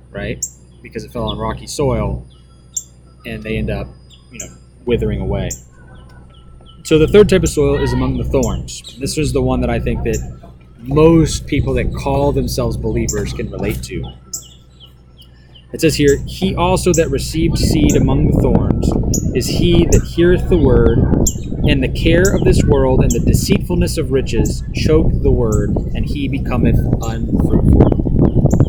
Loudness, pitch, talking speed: -15 LUFS, 105 Hz, 160 wpm